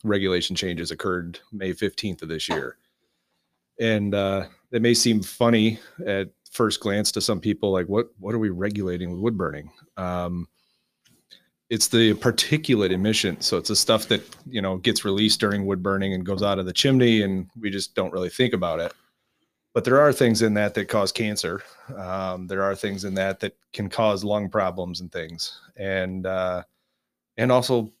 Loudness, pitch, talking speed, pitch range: -23 LUFS, 100 Hz, 185 wpm, 95-110 Hz